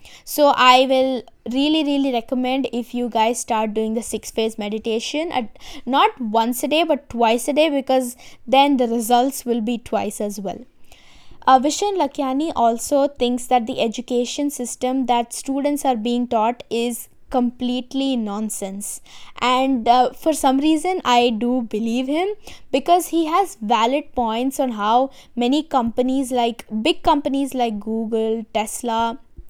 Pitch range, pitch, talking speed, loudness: 230-275 Hz, 250 Hz, 150 wpm, -20 LUFS